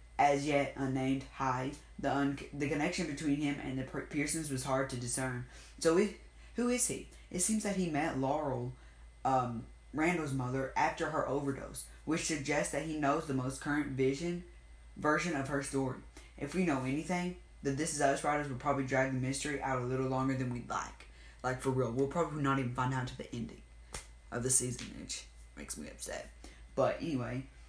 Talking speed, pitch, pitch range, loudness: 195 wpm, 135 Hz, 130-150 Hz, -35 LUFS